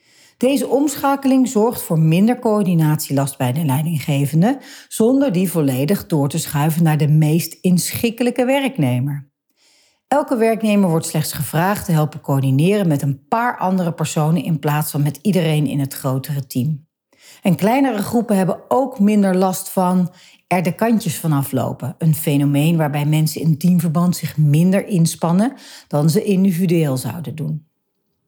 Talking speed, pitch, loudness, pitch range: 145 wpm, 165 Hz, -18 LUFS, 150-210 Hz